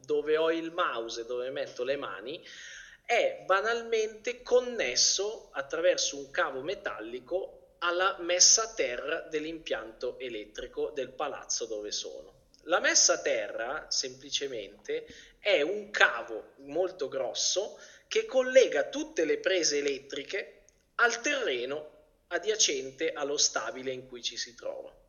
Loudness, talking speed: -29 LUFS, 120 wpm